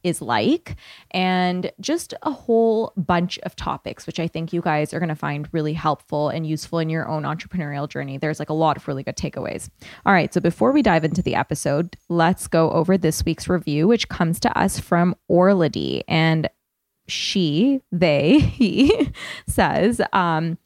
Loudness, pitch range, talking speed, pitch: -21 LUFS, 155-185 Hz, 180 wpm, 170 Hz